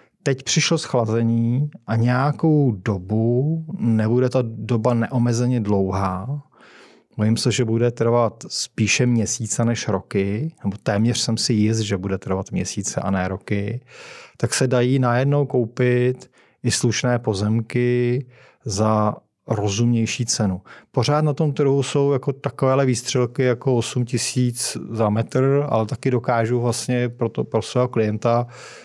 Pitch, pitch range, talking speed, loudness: 120 Hz, 110-130 Hz, 135 wpm, -21 LUFS